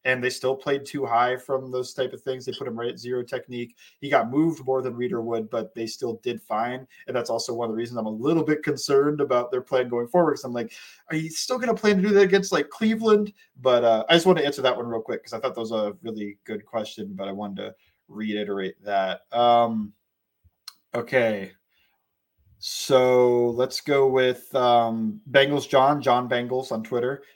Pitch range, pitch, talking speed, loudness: 115-140 Hz, 125 Hz, 220 wpm, -24 LUFS